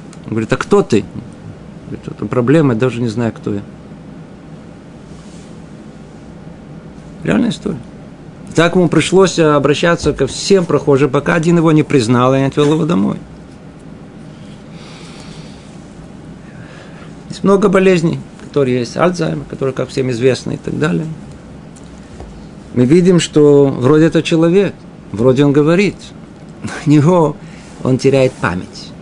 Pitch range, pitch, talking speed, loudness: 130-170 Hz, 150 Hz, 130 wpm, -13 LUFS